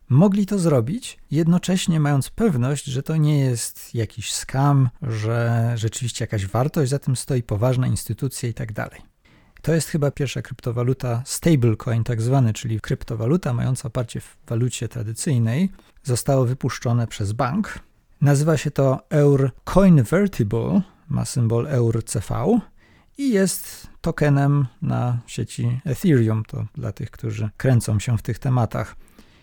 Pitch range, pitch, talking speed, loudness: 115-145 Hz, 130 Hz, 135 wpm, -22 LUFS